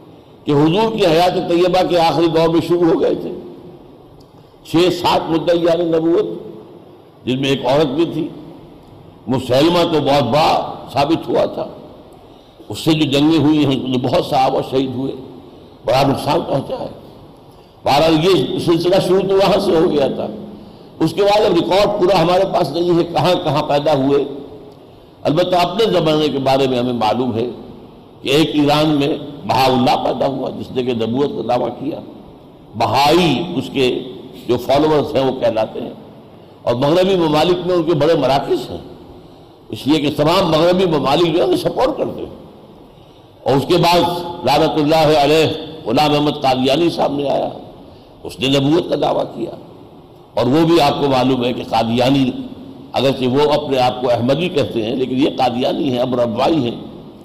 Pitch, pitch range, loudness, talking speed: 155 Hz, 135-175 Hz, -15 LUFS, 170 wpm